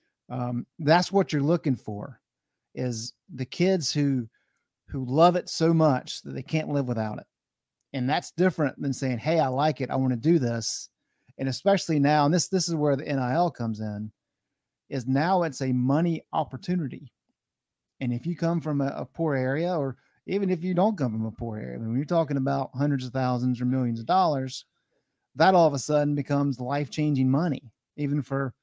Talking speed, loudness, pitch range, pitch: 200 wpm, -26 LUFS, 125-160 Hz, 140 Hz